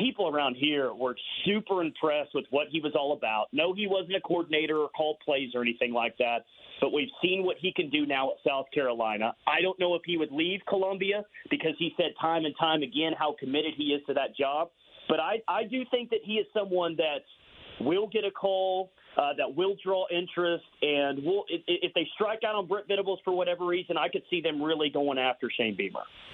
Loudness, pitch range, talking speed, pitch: -29 LUFS, 150-190 Hz, 225 wpm, 170 Hz